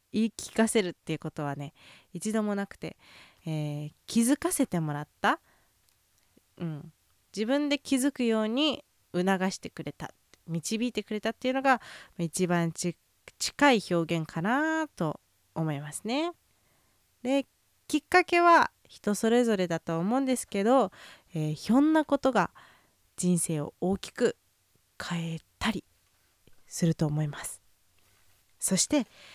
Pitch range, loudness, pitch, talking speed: 160-255 Hz, -29 LUFS, 195 Hz, 255 characters per minute